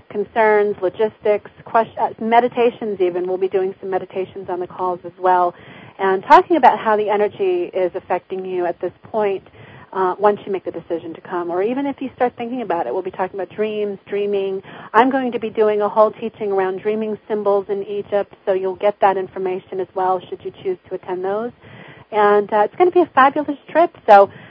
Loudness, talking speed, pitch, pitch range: -19 LUFS, 210 wpm, 200 Hz, 185-220 Hz